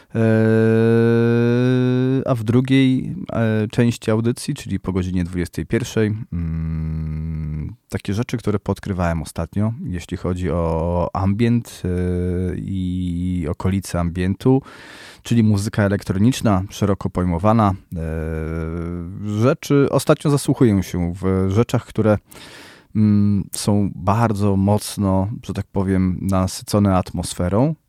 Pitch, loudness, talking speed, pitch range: 100 Hz, -20 LUFS, 100 wpm, 90-115 Hz